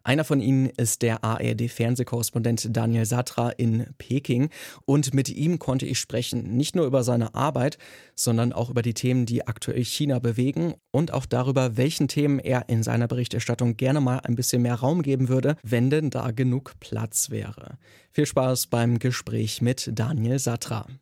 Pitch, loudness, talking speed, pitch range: 125 Hz, -25 LUFS, 170 wpm, 120-135 Hz